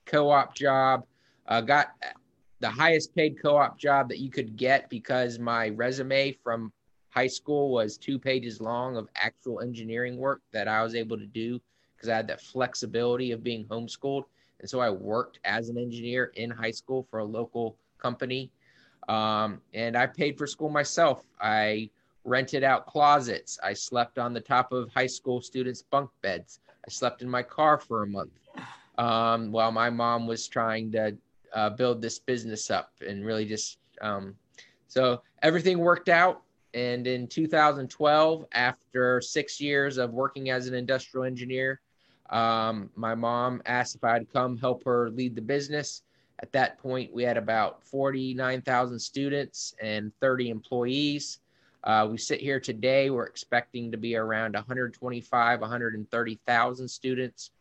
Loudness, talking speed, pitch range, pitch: -28 LUFS, 165 wpm, 115-135 Hz, 125 Hz